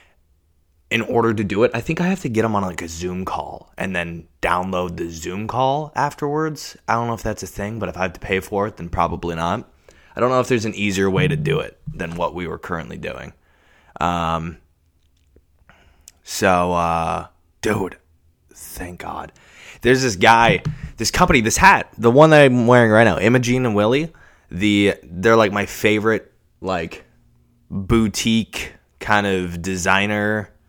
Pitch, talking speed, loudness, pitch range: 95 Hz, 175 wpm, -19 LUFS, 85-115 Hz